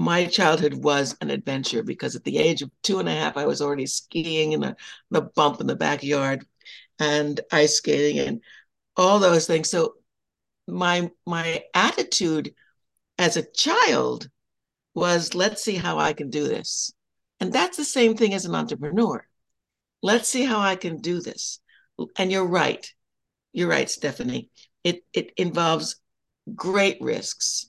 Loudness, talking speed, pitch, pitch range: -23 LUFS, 160 wpm, 175 Hz, 150-195 Hz